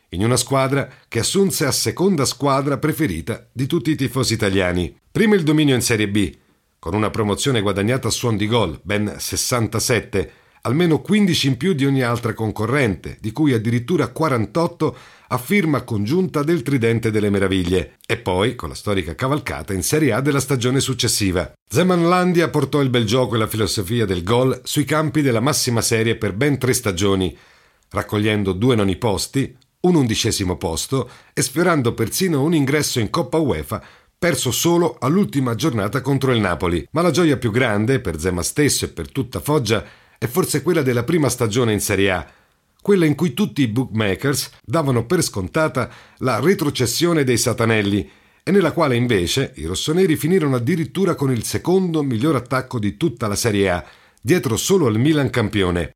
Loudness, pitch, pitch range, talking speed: -19 LUFS, 125 Hz, 105-150 Hz, 170 wpm